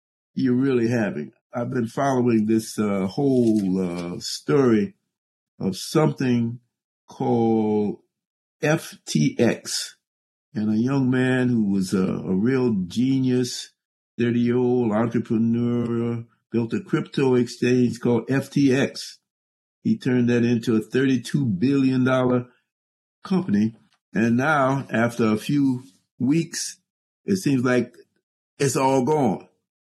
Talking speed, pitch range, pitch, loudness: 105 wpm, 110-130 Hz, 120 Hz, -22 LUFS